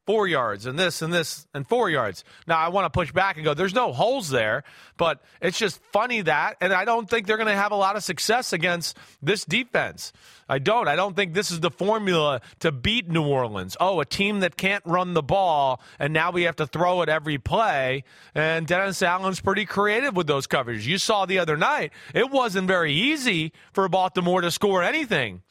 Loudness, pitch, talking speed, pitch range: -23 LUFS, 180 Hz, 215 wpm, 160-200 Hz